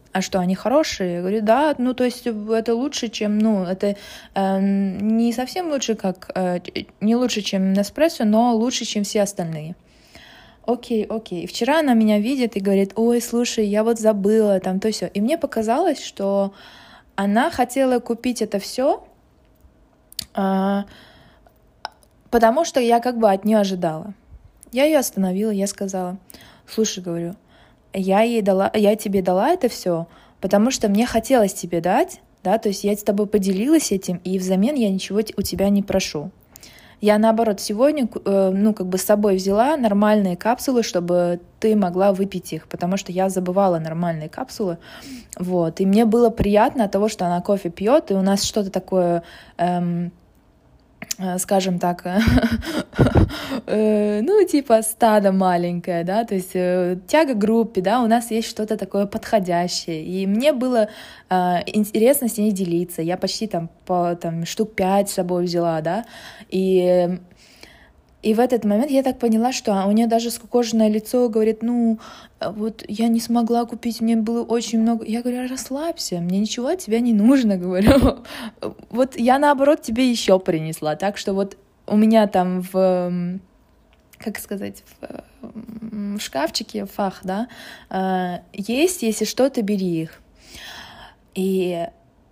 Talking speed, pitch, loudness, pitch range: 155 wpm, 210 Hz, -20 LUFS, 190-235 Hz